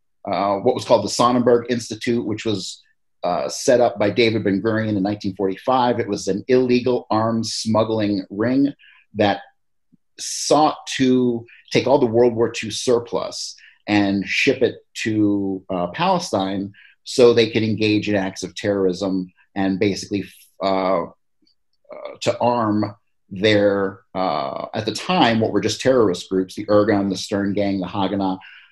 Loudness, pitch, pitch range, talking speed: -20 LUFS, 105 Hz, 95-115 Hz, 150 wpm